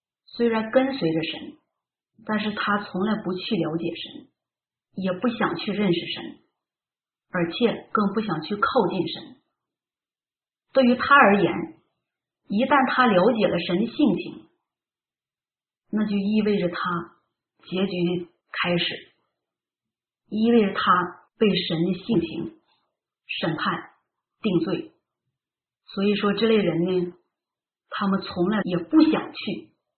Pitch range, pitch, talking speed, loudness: 175-220 Hz, 195 Hz, 170 characters per minute, -23 LUFS